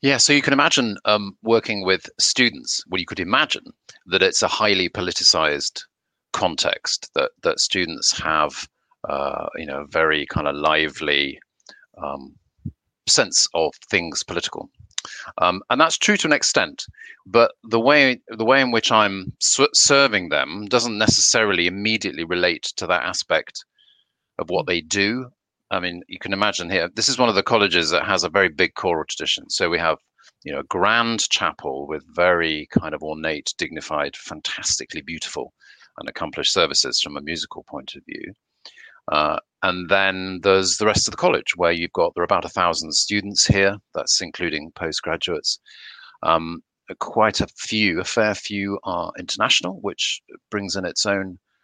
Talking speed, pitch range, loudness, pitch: 165 wpm, 95-120 Hz, -20 LUFS, 105 Hz